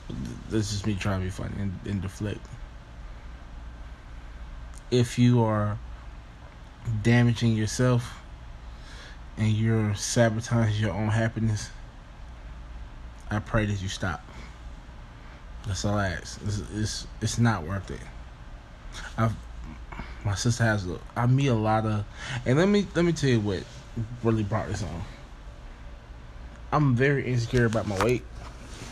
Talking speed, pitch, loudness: 130 wpm, 105 Hz, -27 LUFS